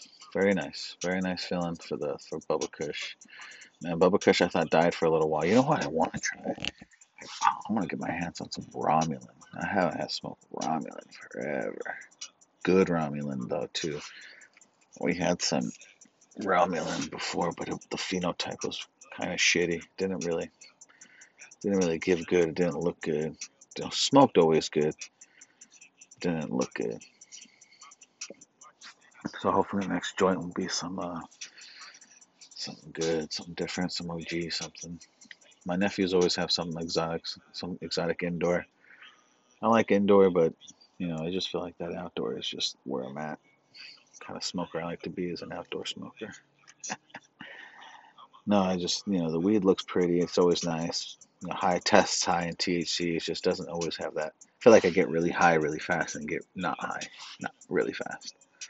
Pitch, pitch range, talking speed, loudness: 85 Hz, 85-90 Hz, 170 wpm, -29 LUFS